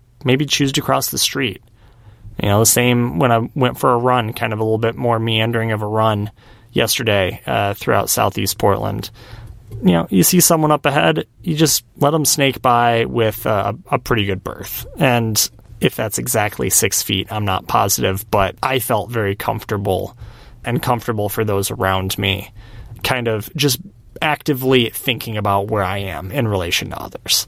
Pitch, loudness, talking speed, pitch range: 115 Hz, -17 LUFS, 180 wpm, 100-125 Hz